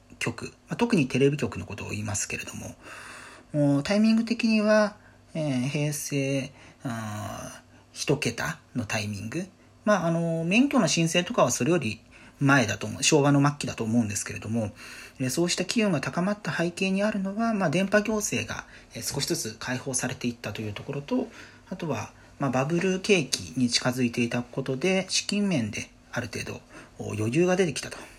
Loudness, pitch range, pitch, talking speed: -26 LUFS, 115-175 Hz, 135 Hz, 315 characters per minute